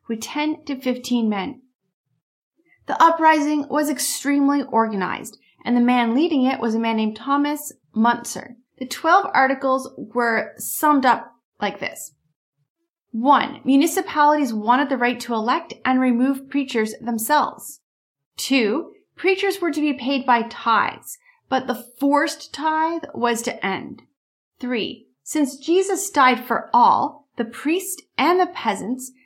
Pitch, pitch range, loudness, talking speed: 265 Hz, 235-300 Hz, -20 LUFS, 135 wpm